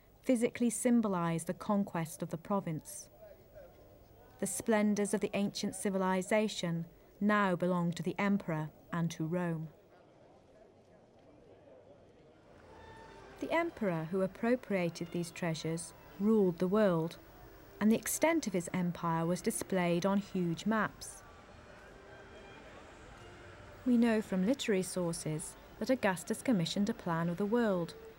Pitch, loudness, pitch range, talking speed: 190 Hz, -34 LUFS, 170-215 Hz, 115 wpm